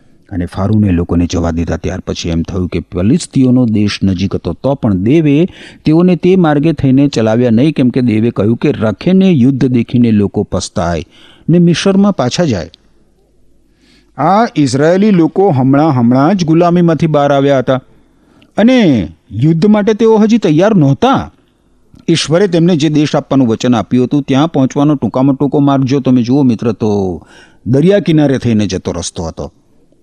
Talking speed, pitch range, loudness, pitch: 155 wpm, 105-165 Hz, -11 LUFS, 135 Hz